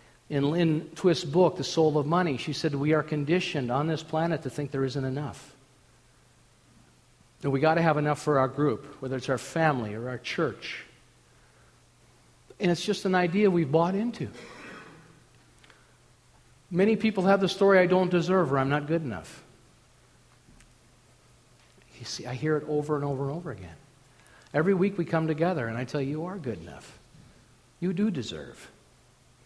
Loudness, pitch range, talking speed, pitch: -27 LUFS, 135-175 Hz, 175 wpm, 150 Hz